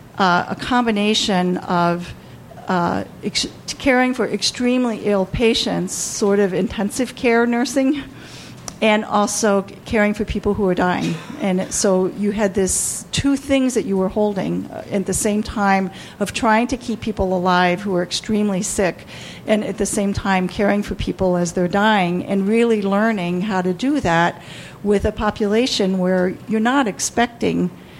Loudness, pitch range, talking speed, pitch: -19 LUFS, 190-225 Hz, 165 wpm, 205 Hz